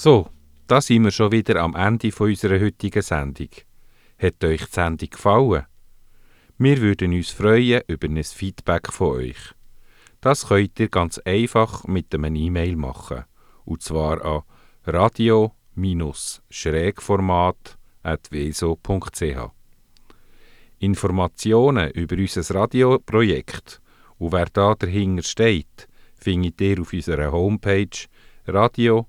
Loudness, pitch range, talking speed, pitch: -21 LUFS, 80-110 Hz, 110 wpm, 95 Hz